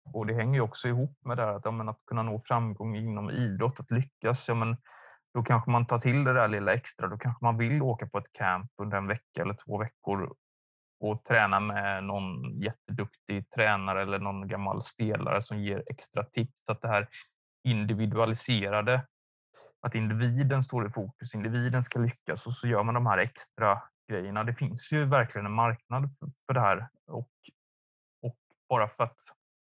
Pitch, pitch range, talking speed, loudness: 115 Hz, 105-125 Hz, 185 wpm, -30 LUFS